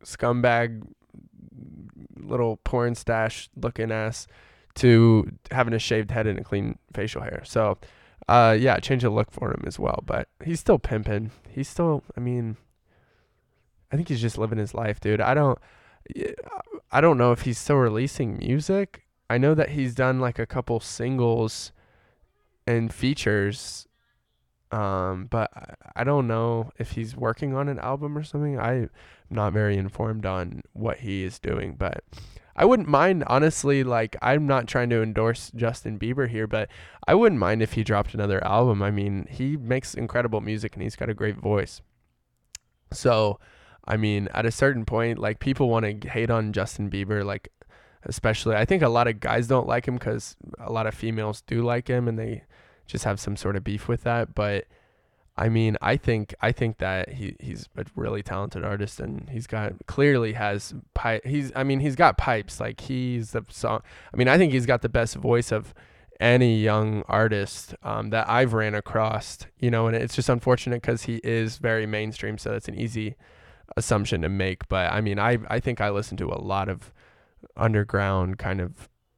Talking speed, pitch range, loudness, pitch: 185 wpm, 105-125 Hz, -25 LUFS, 115 Hz